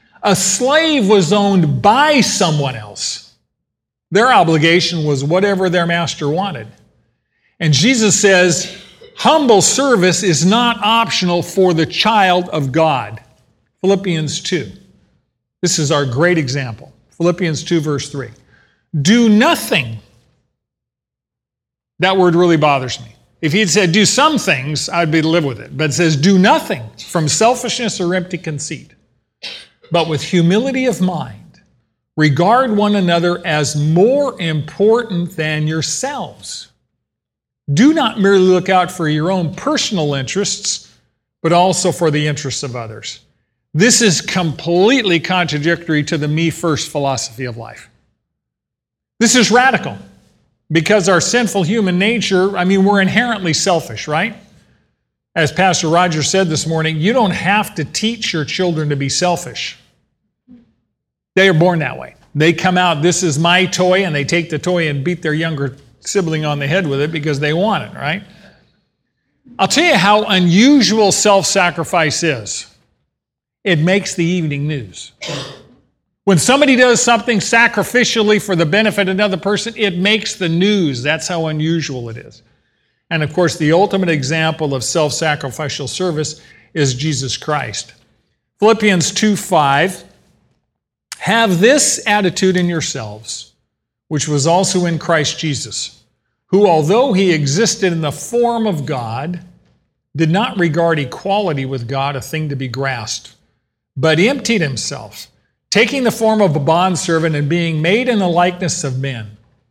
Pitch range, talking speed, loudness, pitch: 150-200 Hz, 145 wpm, -14 LUFS, 170 Hz